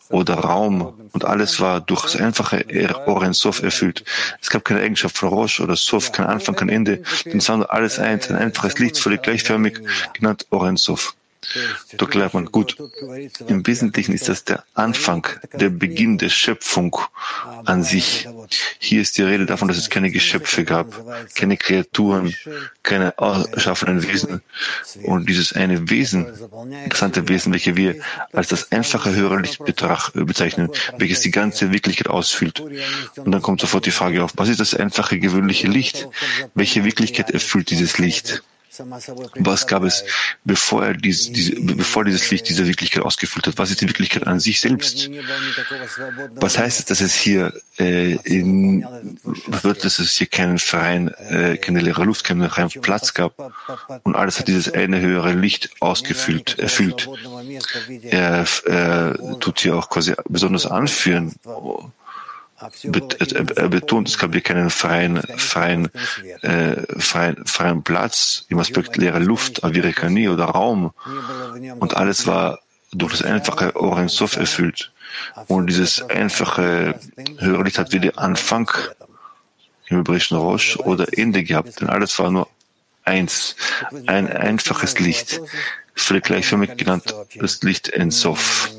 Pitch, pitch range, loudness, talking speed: 95 Hz, 90-110 Hz, -18 LUFS, 145 wpm